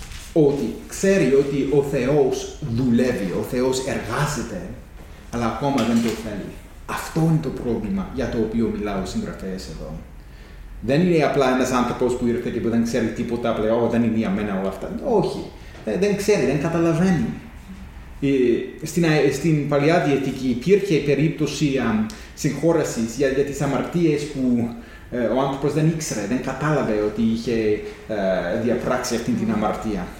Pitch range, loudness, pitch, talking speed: 115-150 Hz, -21 LUFS, 125 Hz, 140 wpm